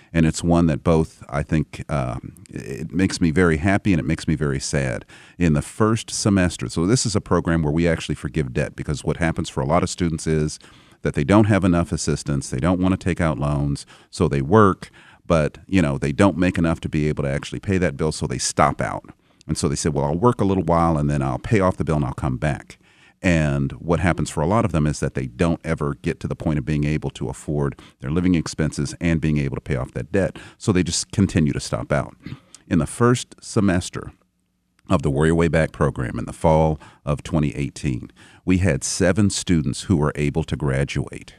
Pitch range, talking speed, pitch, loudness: 75-90 Hz, 235 wpm, 80 Hz, -21 LUFS